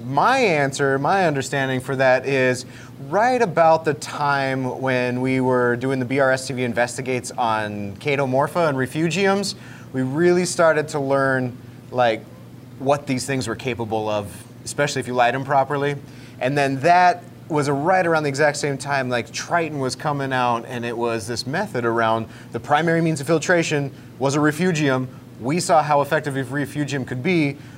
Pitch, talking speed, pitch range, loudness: 135 Hz, 165 wpm, 125-150 Hz, -21 LUFS